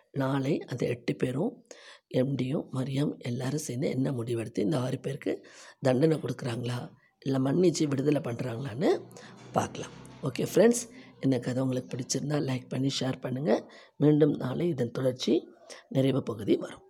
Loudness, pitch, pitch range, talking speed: -30 LUFS, 135 Hz, 125-145 Hz, 130 wpm